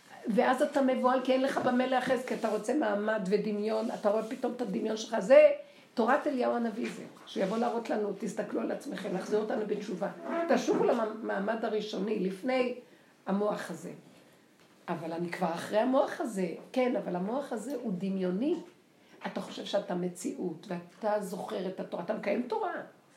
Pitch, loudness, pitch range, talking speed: 220 Hz, -31 LUFS, 200-255 Hz, 160 wpm